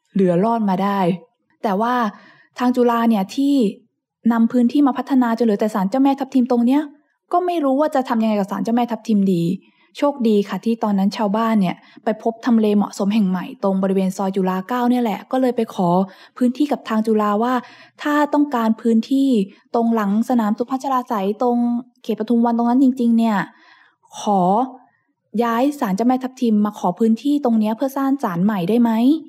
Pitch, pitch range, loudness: 230 Hz, 210-250 Hz, -19 LUFS